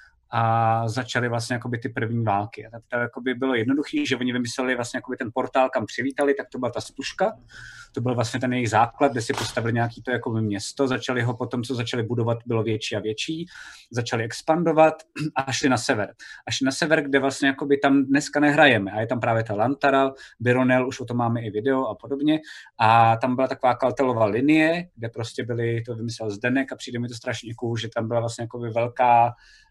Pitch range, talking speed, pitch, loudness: 115-135 Hz, 200 wpm, 125 Hz, -23 LUFS